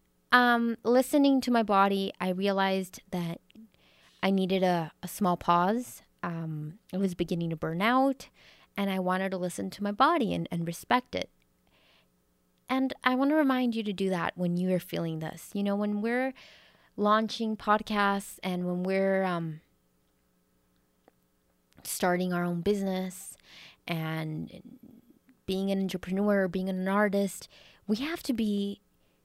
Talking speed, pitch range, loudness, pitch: 150 wpm, 170-215 Hz, -29 LUFS, 190 Hz